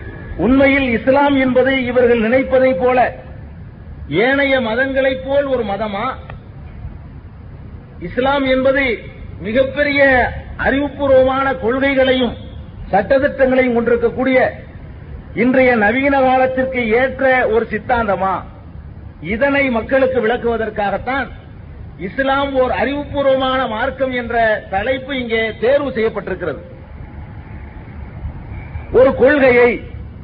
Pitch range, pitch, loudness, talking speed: 200-265 Hz, 250 Hz, -15 LUFS, 75 wpm